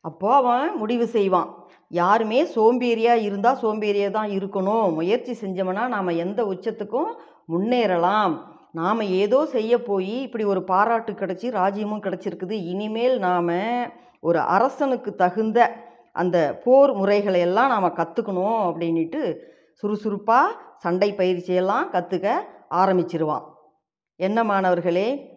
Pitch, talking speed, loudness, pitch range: 200 Hz, 105 wpm, -22 LUFS, 180-230 Hz